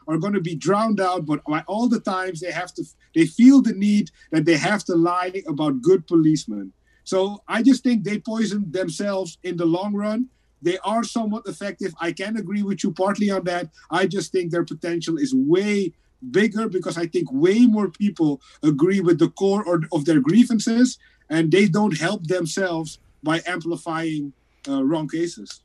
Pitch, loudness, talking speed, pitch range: 190 Hz, -21 LUFS, 185 wpm, 170-215 Hz